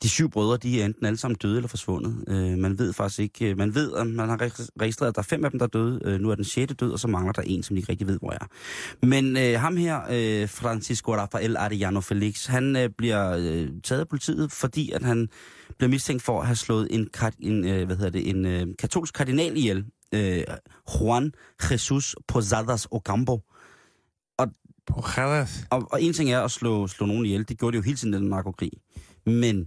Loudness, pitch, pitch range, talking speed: -26 LUFS, 115 Hz, 100-125 Hz, 220 wpm